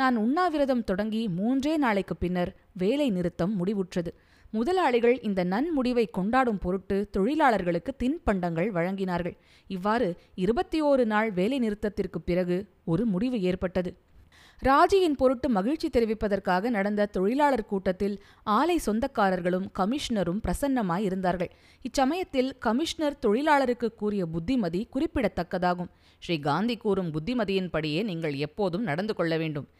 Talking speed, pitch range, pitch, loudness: 110 wpm, 180-255 Hz, 210 Hz, -27 LUFS